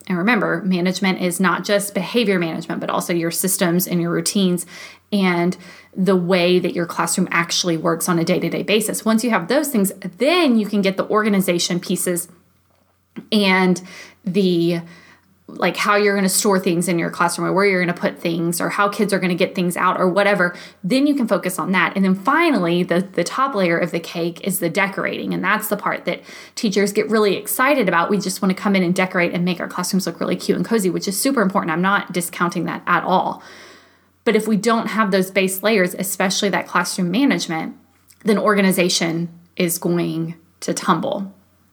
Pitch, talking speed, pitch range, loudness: 185 Hz, 210 wpm, 175-205 Hz, -19 LUFS